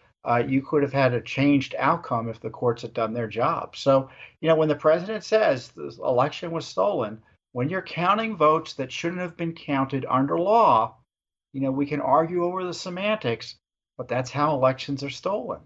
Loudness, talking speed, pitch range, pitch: -24 LUFS, 195 wpm, 125-165 Hz, 140 Hz